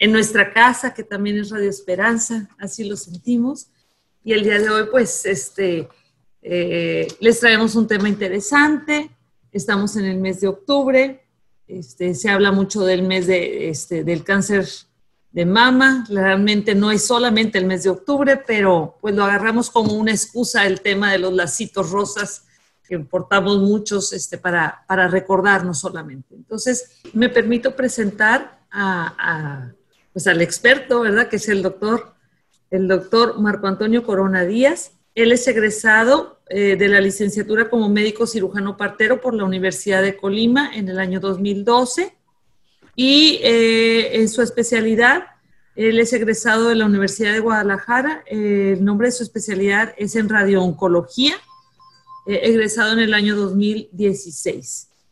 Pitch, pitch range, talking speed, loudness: 210 Hz, 195-230 Hz, 150 wpm, -17 LUFS